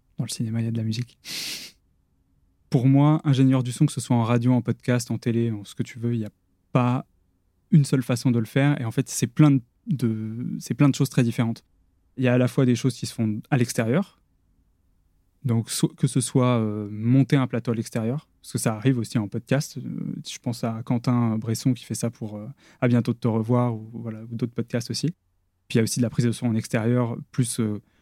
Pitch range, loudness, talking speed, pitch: 110-130 Hz, -24 LUFS, 250 wpm, 120 Hz